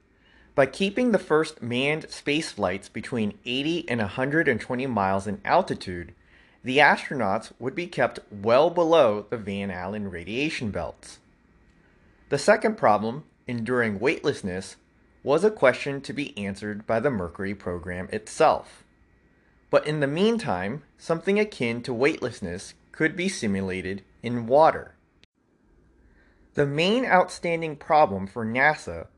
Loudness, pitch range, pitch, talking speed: -25 LUFS, 100-155 Hz, 125 Hz, 125 wpm